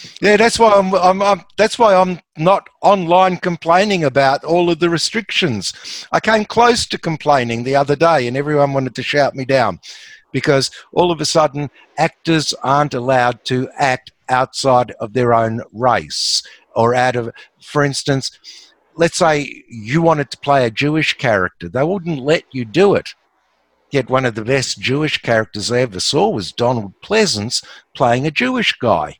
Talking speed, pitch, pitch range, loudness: 175 wpm, 145 Hz, 125-170 Hz, -16 LUFS